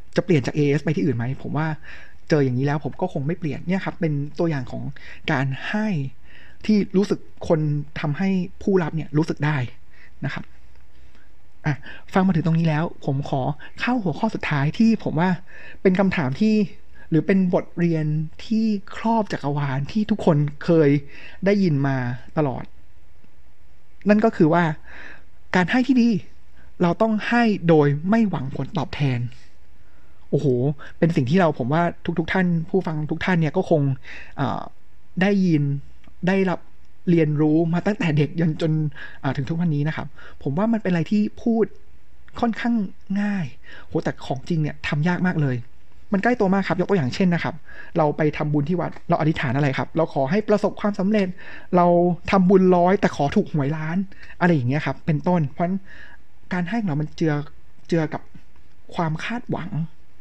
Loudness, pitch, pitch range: -22 LUFS, 160 Hz, 140-190 Hz